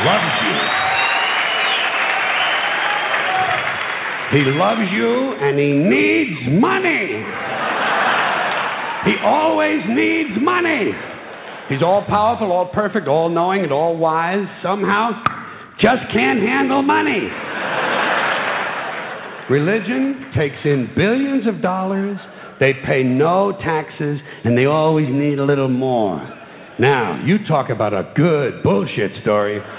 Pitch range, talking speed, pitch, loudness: 140-220 Hz, 105 wpm, 180 Hz, -17 LUFS